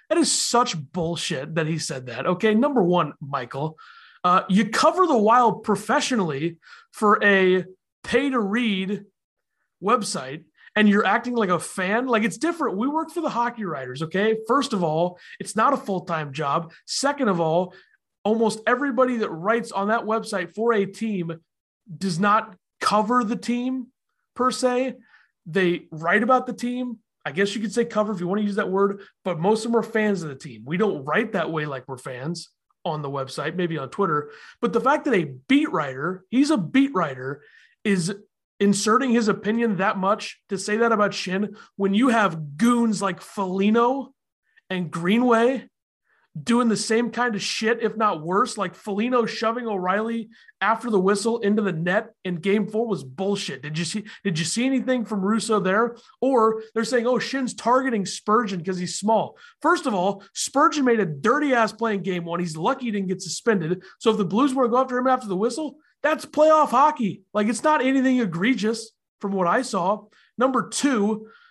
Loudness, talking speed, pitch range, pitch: -23 LUFS, 190 wpm, 185-240 Hz, 215 Hz